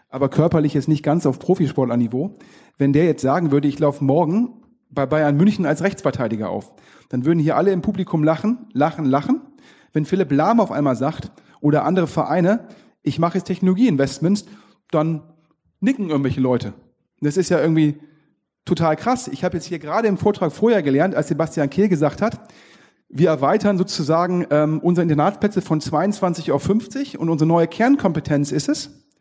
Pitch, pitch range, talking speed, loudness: 165 Hz, 145-195 Hz, 175 wpm, -19 LUFS